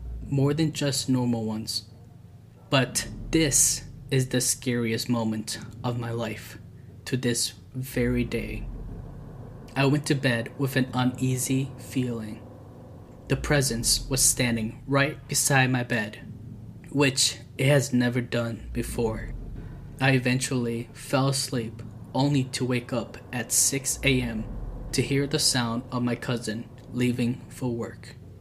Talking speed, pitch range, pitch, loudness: 130 wpm, 115-135 Hz, 125 Hz, -26 LUFS